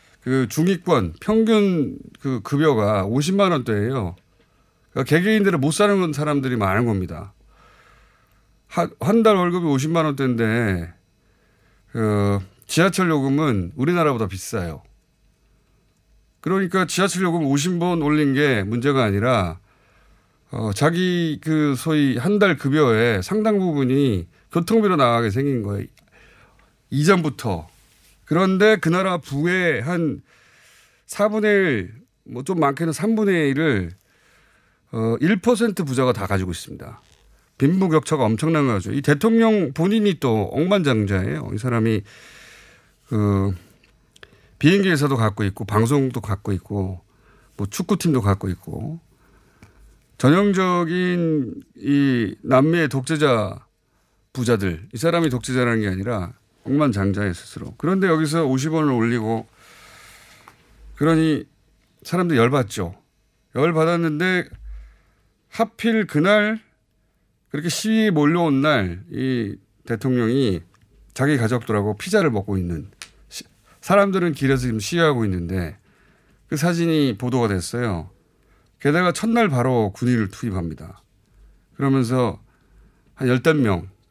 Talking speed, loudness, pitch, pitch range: 245 characters per minute, -20 LUFS, 130 Hz, 105-165 Hz